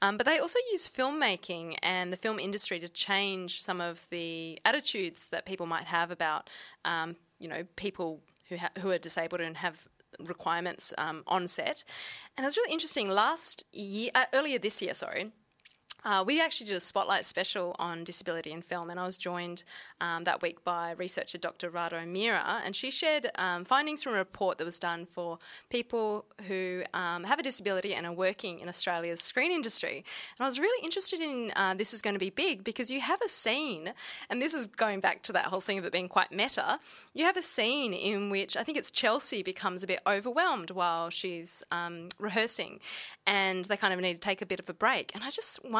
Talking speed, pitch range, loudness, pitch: 210 wpm, 175-235 Hz, -31 LUFS, 190 Hz